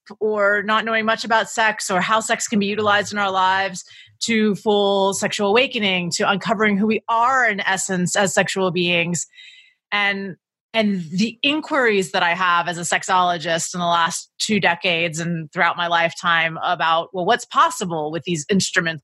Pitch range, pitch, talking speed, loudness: 175-215 Hz, 195 Hz, 175 wpm, -19 LUFS